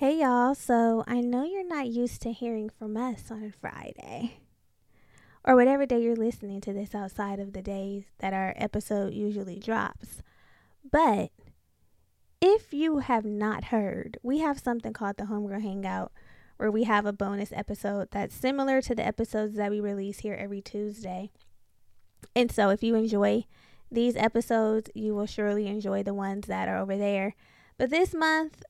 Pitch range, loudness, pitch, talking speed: 200-240 Hz, -29 LUFS, 215 Hz, 170 wpm